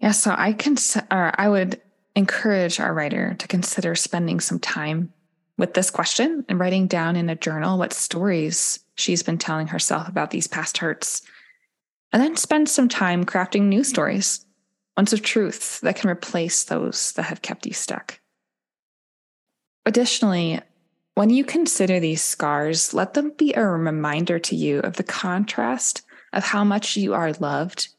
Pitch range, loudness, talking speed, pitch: 170-215 Hz, -22 LUFS, 165 wpm, 185 Hz